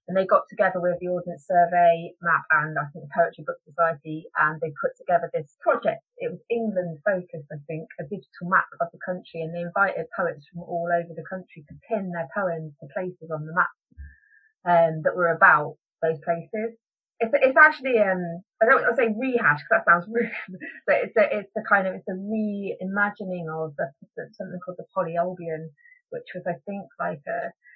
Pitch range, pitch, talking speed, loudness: 165-205 Hz, 175 Hz, 200 wpm, -24 LUFS